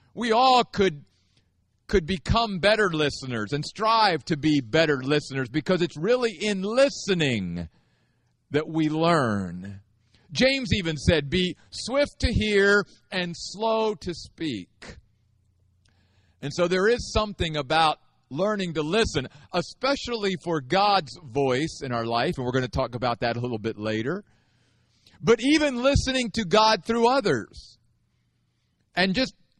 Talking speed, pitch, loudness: 140 wpm, 160 Hz, -24 LUFS